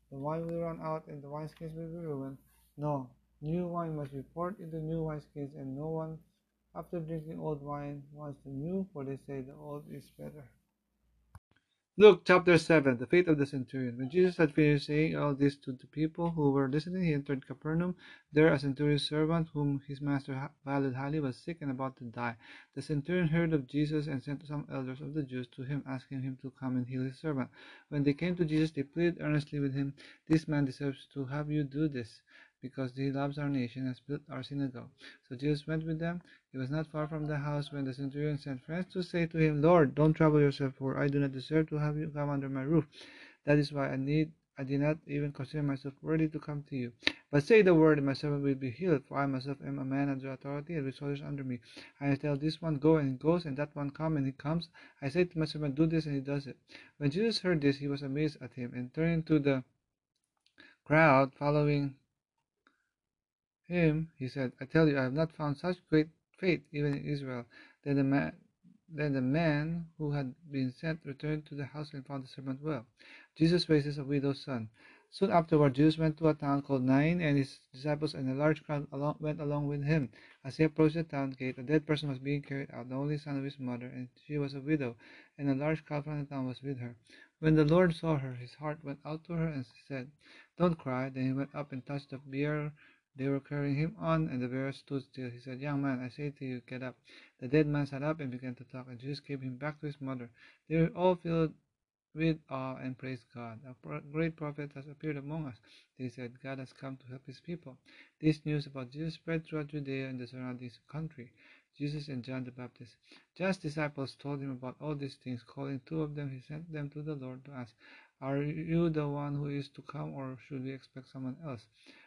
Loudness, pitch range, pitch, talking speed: -33 LUFS, 135-155 Hz, 145 Hz, 235 wpm